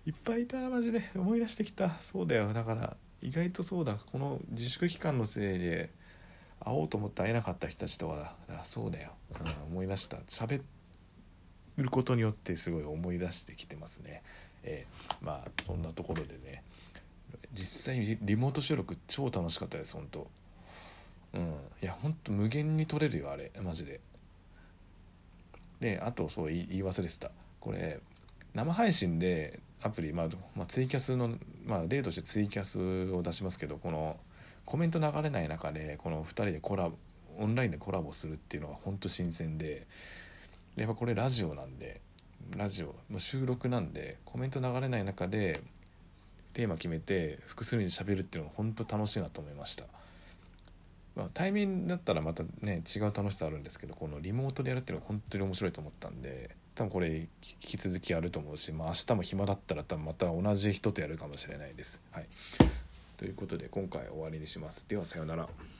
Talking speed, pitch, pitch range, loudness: 360 characters per minute, 95 Hz, 85-115 Hz, -36 LUFS